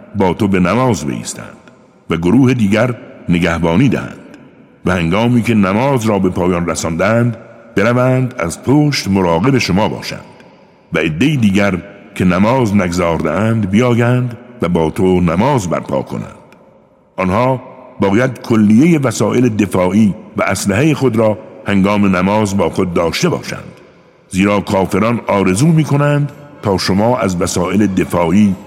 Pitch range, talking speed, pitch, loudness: 95-125 Hz, 130 wpm, 105 Hz, -14 LUFS